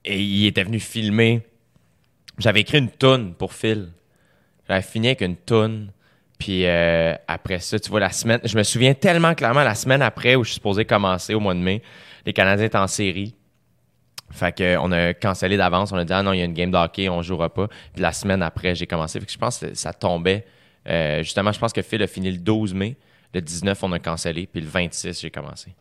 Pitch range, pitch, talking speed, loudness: 90-110 Hz, 95 Hz, 235 wpm, -21 LUFS